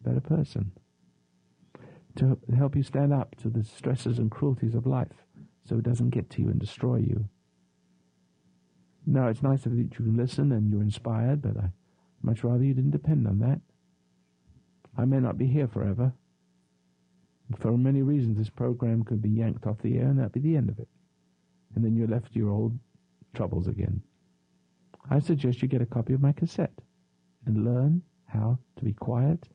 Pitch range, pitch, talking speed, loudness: 100-130 Hz, 115 Hz, 185 wpm, -28 LUFS